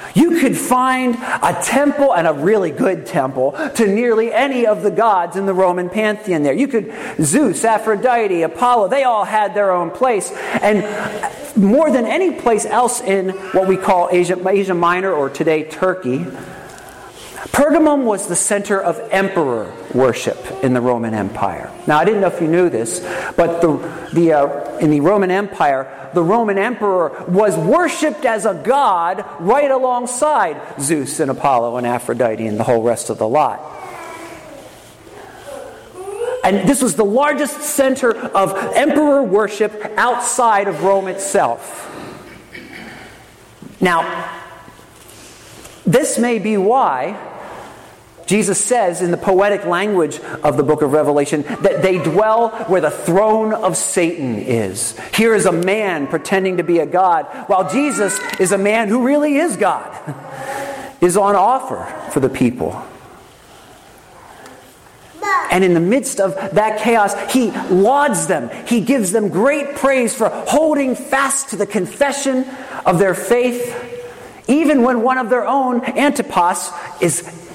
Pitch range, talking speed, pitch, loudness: 180-255 Hz, 145 wpm, 210 Hz, -16 LUFS